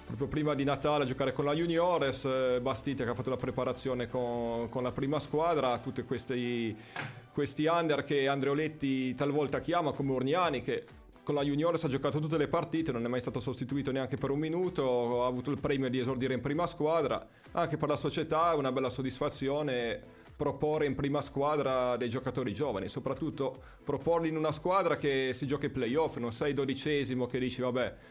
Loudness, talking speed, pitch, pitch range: -32 LUFS, 190 wpm, 140 Hz, 130-150 Hz